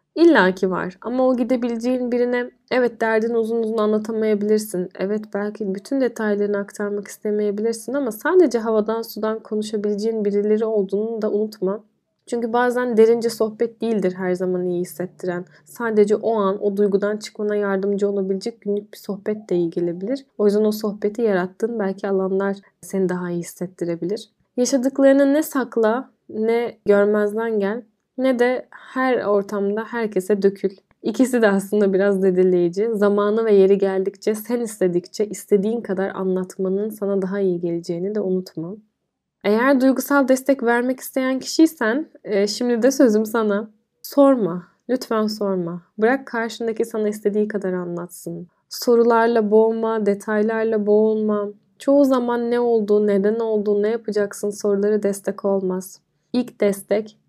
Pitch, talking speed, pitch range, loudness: 210 Hz, 135 wpm, 195-230 Hz, -20 LUFS